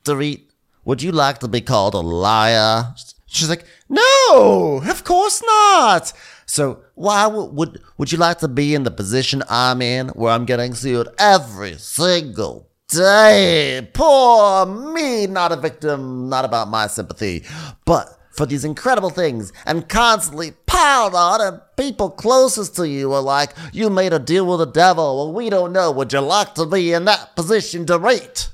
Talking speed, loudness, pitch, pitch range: 170 wpm, -16 LUFS, 165 Hz, 130-205 Hz